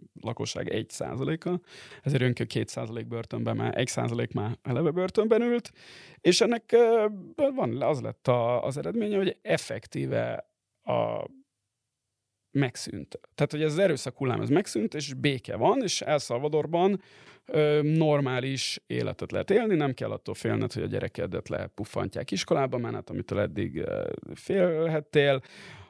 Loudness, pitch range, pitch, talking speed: -28 LUFS, 125-185 Hz, 150 Hz, 135 wpm